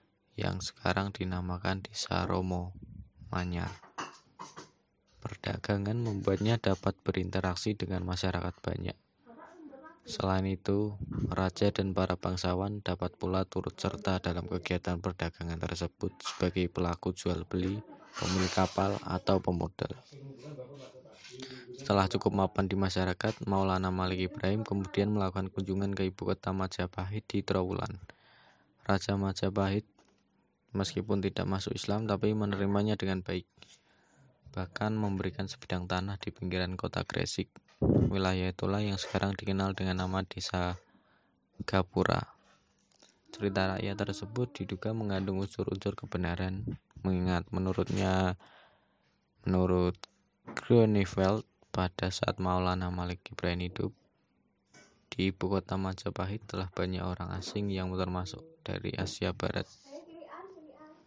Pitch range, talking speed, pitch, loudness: 90-100 Hz, 110 wpm, 95 Hz, -33 LUFS